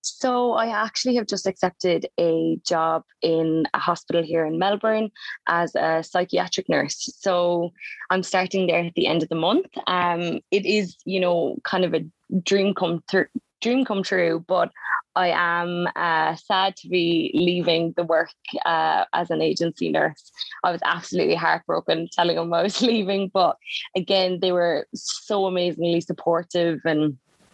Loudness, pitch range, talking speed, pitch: -23 LUFS, 170-195 Hz, 160 wpm, 175 Hz